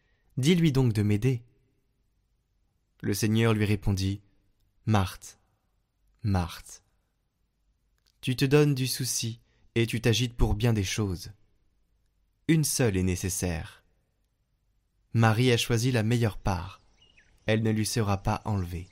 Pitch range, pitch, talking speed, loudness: 100-120 Hz, 105 Hz, 125 wpm, -27 LUFS